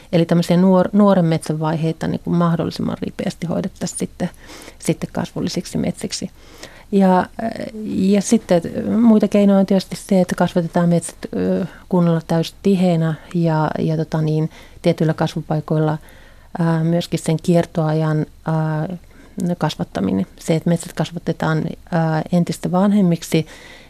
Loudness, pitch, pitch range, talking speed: -19 LUFS, 170 Hz, 160-190 Hz, 115 wpm